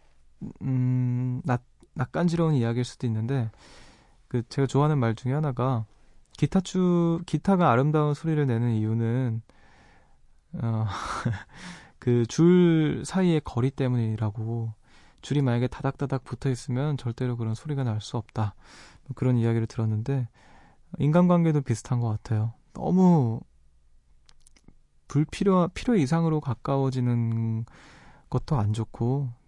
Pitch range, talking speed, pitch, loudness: 115-150 Hz, 265 characters per minute, 125 Hz, -26 LUFS